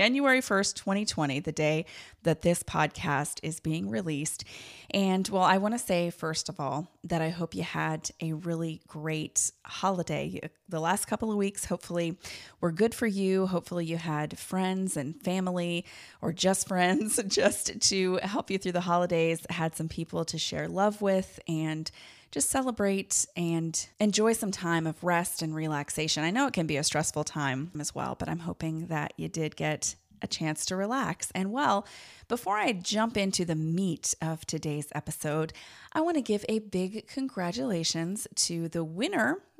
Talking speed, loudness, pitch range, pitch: 175 wpm, -30 LUFS, 155-195 Hz, 170 Hz